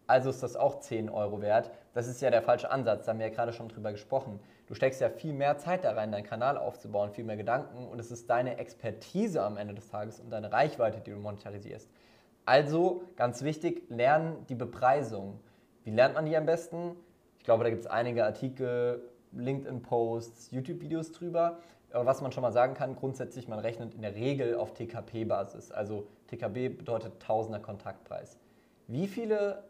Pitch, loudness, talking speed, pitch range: 120 Hz, -32 LUFS, 200 wpm, 110-140 Hz